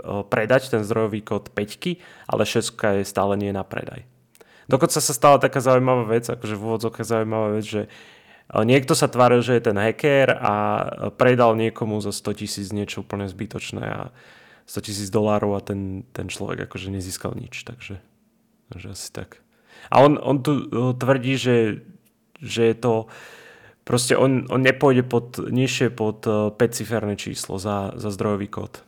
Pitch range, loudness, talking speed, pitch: 105-125 Hz, -21 LUFS, 160 wpm, 115 Hz